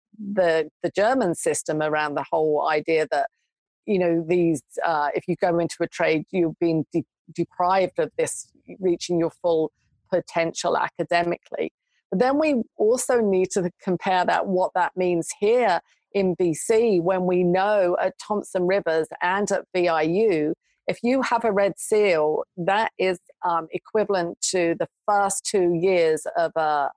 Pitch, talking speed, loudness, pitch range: 180 Hz, 155 wpm, -23 LUFS, 165-205 Hz